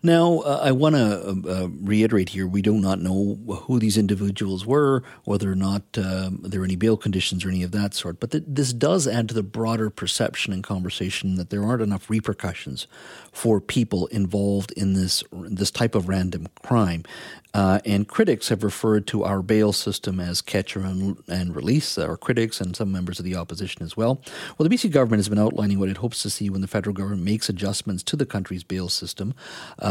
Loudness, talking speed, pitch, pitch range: -23 LUFS, 215 wpm, 100 Hz, 95-110 Hz